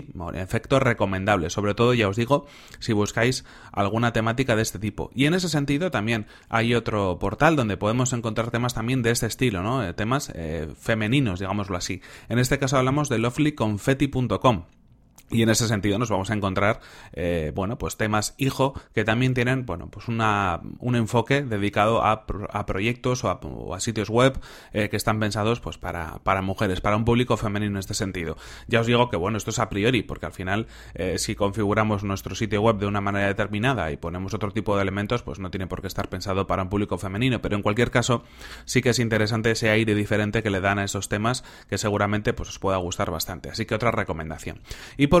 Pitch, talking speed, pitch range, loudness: 110 Hz, 210 wpm, 100-120 Hz, -24 LUFS